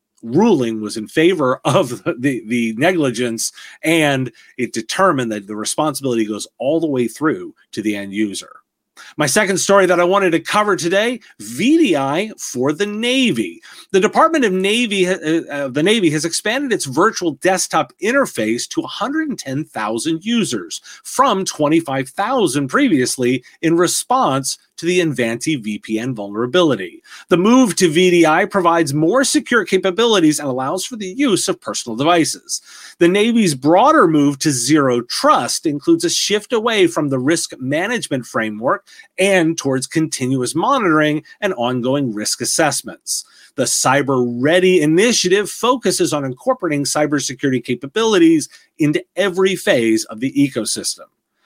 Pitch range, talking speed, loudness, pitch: 130-205 Hz, 140 wpm, -16 LUFS, 165 Hz